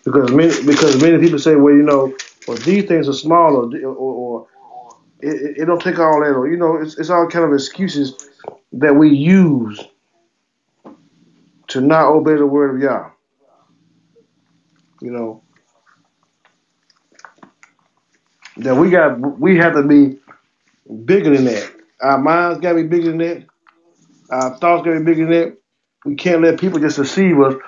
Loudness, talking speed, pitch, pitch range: -14 LUFS, 170 wpm, 155 Hz, 140-170 Hz